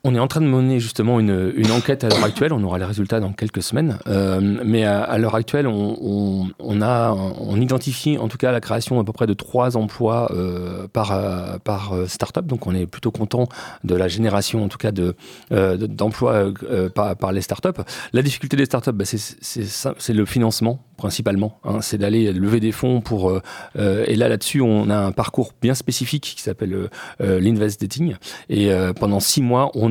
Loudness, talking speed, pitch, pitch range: -20 LUFS, 215 wpm, 110 Hz, 100-125 Hz